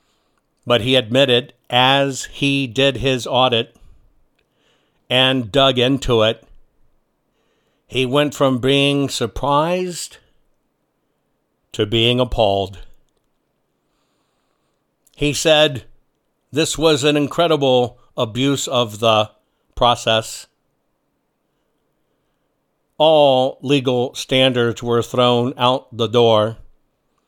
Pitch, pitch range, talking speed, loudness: 130 Hz, 120-140 Hz, 85 wpm, -17 LUFS